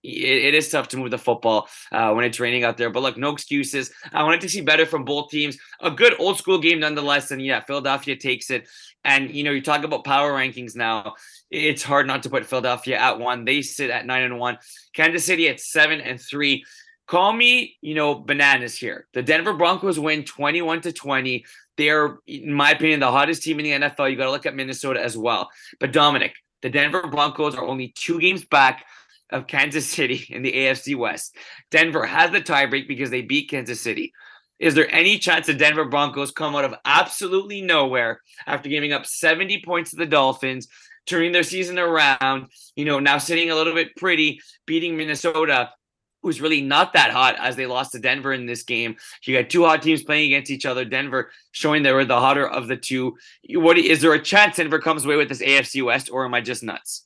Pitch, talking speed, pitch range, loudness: 145 Hz, 215 wpm, 130-160 Hz, -20 LUFS